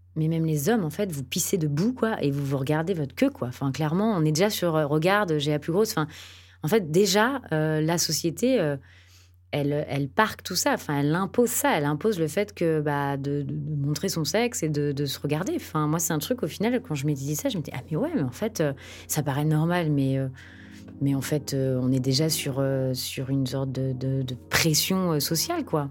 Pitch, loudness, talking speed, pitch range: 150 Hz, -26 LUFS, 250 wpm, 140-175 Hz